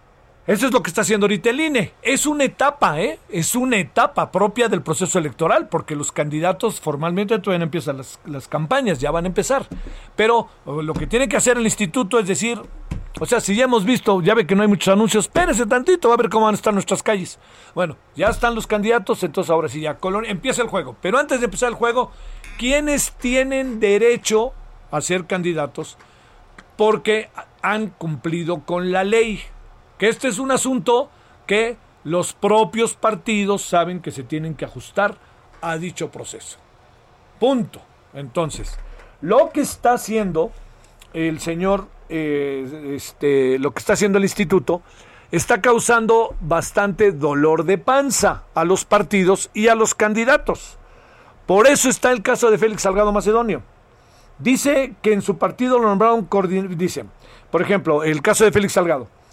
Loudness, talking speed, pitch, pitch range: -19 LUFS, 170 wpm, 205 Hz, 165-235 Hz